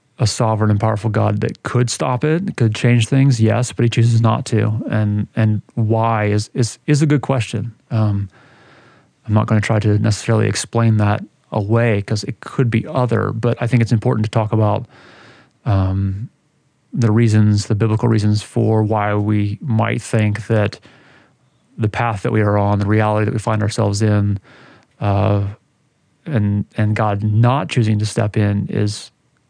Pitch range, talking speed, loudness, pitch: 105-120 Hz, 175 wpm, -17 LUFS, 110 Hz